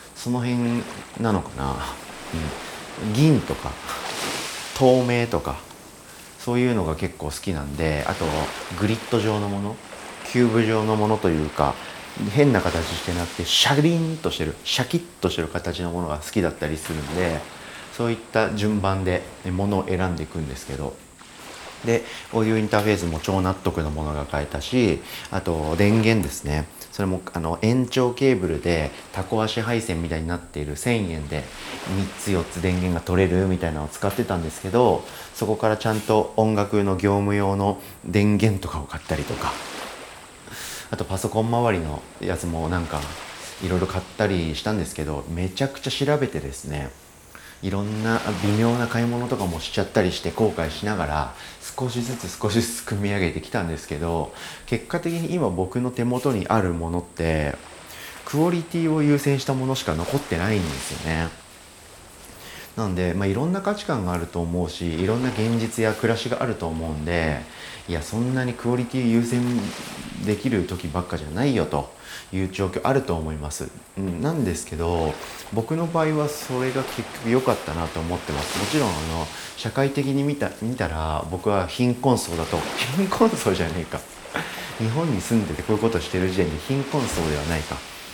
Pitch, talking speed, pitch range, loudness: 95 Hz, 350 characters per minute, 85-115 Hz, -24 LUFS